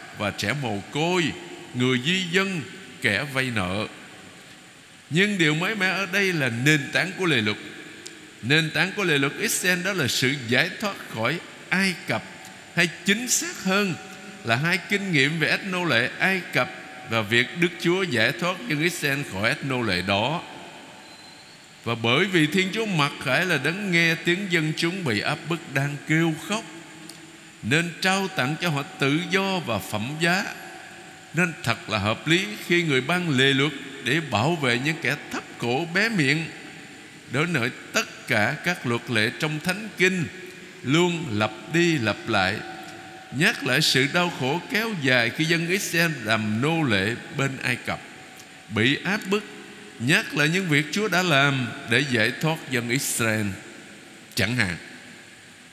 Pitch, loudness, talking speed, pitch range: 155 Hz, -23 LUFS, 170 wpm, 130-180 Hz